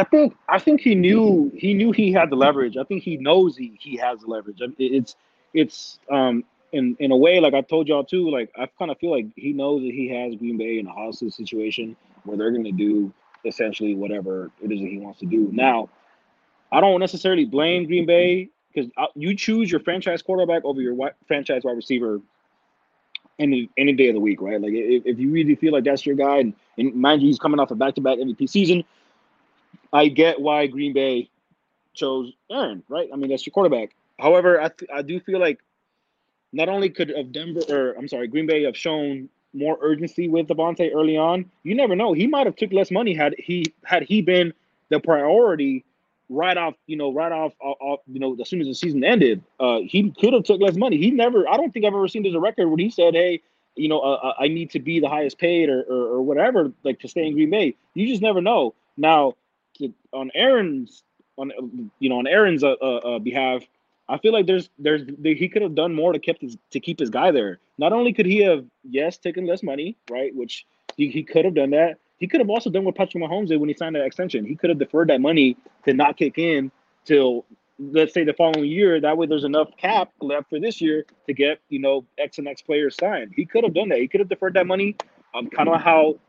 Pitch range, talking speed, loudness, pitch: 135-185 Hz, 235 wpm, -21 LUFS, 155 Hz